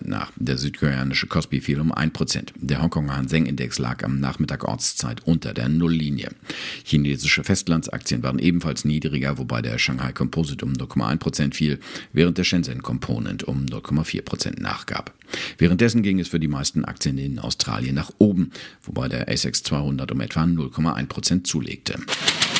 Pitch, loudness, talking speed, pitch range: 75 Hz, -23 LUFS, 150 wpm, 70-80 Hz